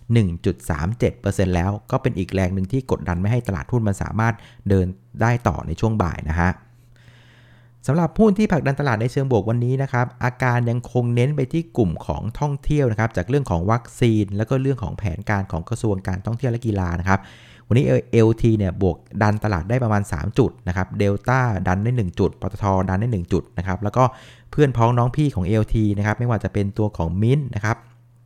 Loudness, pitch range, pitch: -21 LUFS, 95-120 Hz, 110 Hz